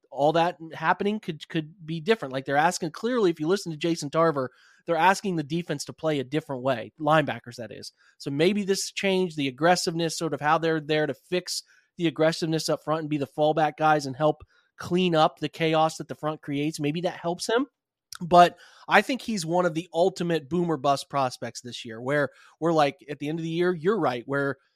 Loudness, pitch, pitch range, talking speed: -26 LUFS, 160 Hz, 145-175 Hz, 220 wpm